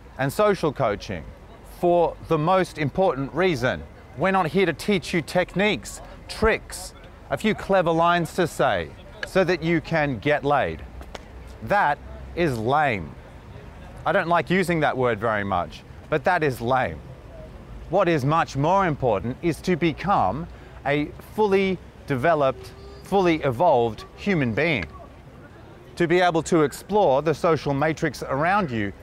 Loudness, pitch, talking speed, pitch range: -23 LUFS, 160 Hz, 140 wpm, 125-180 Hz